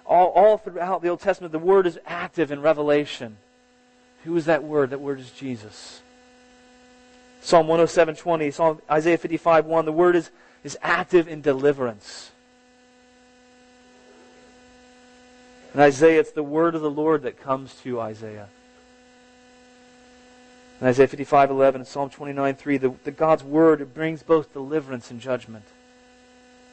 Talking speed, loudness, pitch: 140 wpm, -21 LUFS, 165 Hz